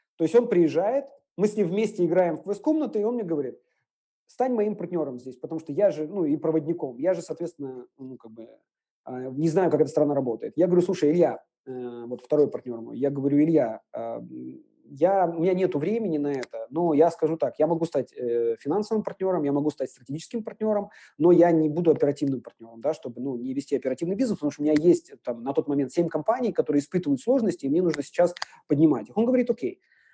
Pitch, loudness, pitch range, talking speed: 160 Hz, -25 LUFS, 140-190 Hz, 210 wpm